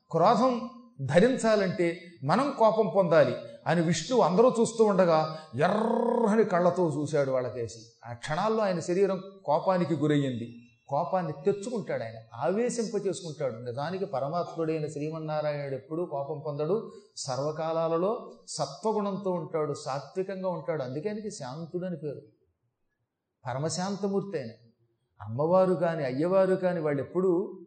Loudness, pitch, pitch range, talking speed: -28 LUFS, 170 Hz, 145-195 Hz, 100 wpm